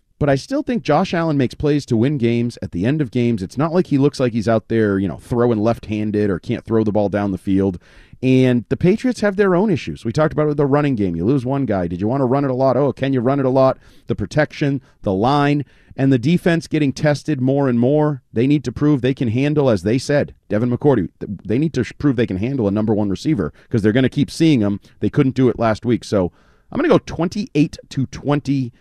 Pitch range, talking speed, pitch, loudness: 110-145 Hz, 265 wpm, 130 Hz, -18 LUFS